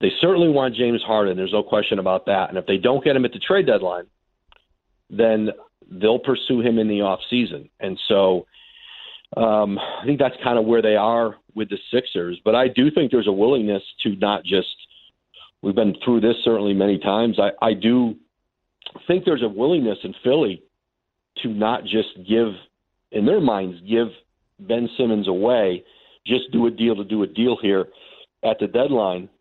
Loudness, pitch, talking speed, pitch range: -20 LUFS, 110 Hz, 185 wpm, 100-120 Hz